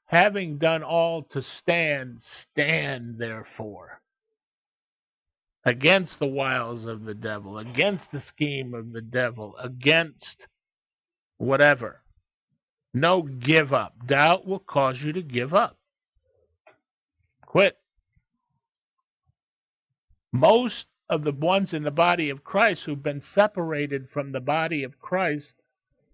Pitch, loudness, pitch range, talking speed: 150 Hz, -24 LUFS, 130-170 Hz, 115 wpm